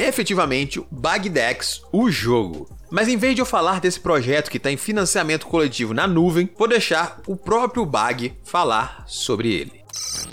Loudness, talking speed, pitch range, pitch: -20 LUFS, 175 wpm, 145-215 Hz, 180 Hz